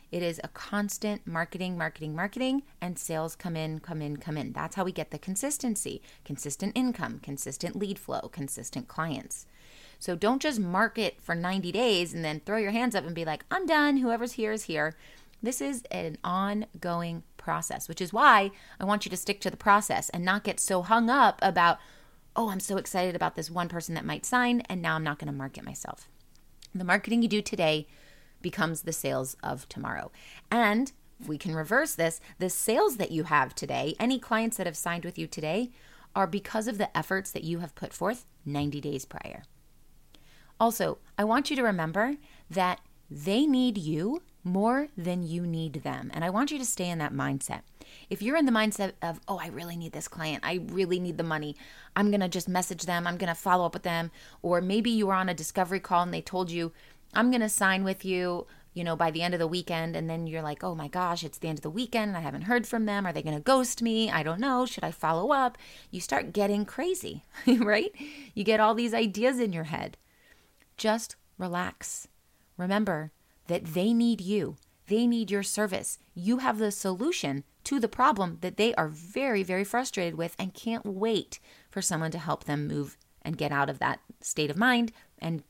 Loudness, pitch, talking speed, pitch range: -29 LUFS, 185 Hz, 210 wpm, 165-220 Hz